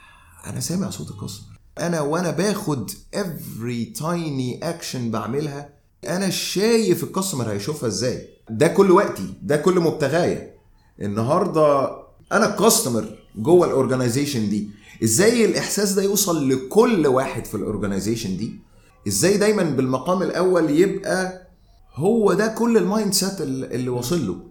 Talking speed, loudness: 120 wpm, -21 LUFS